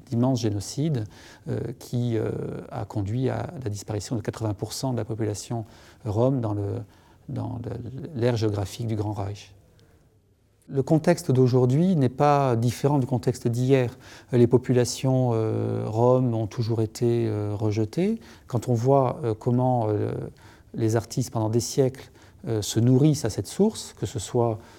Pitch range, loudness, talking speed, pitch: 110-130 Hz, -25 LUFS, 155 wpm, 120 Hz